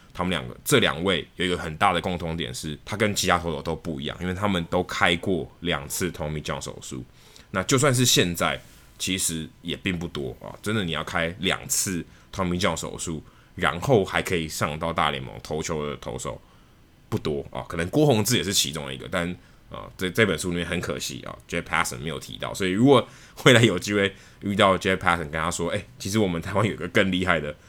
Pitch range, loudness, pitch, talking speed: 80-100 Hz, -24 LUFS, 90 Hz, 370 characters per minute